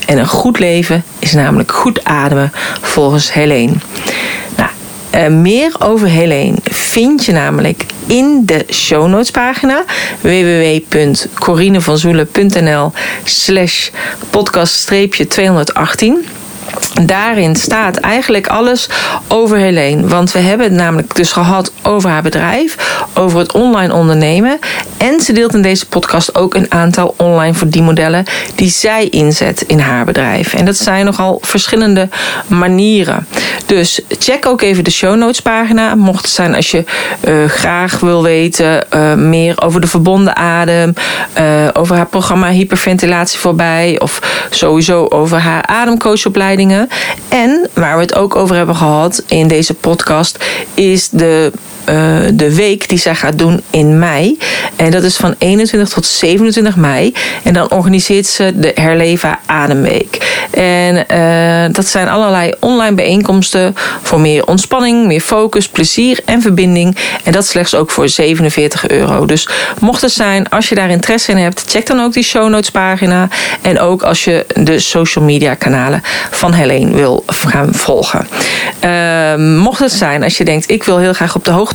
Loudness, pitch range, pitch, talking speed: -9 LUFS, 165-215 Hz, 185 Hz, 150 wpm